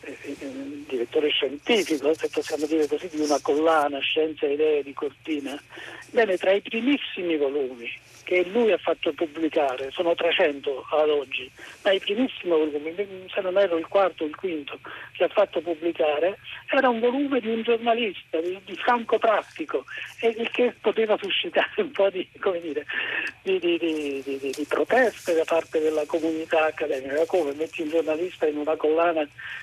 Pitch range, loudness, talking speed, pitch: 155-230 Hz, -25 LUFS, 160 wpm, 175 Hz